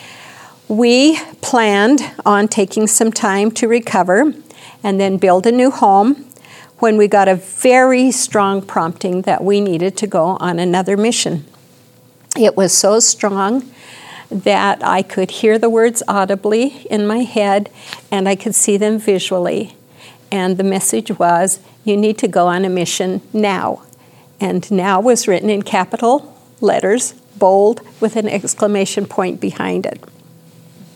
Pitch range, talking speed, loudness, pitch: 190-225 Hz, 145 wpm, -14 LUFS, 200 Hz